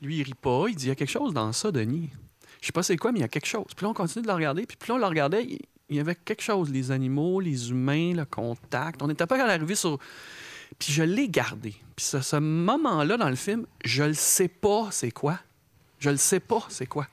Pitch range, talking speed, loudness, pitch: 135-190 Hz, 275 wpm, -27 LUFS, 150 Hz